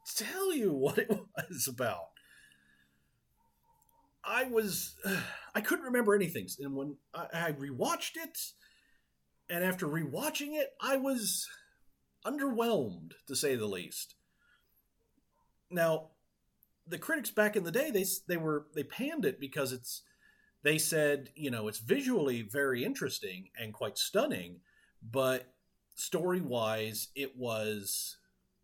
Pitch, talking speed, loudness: 170 Hz, 130 wpm, -34 LUFS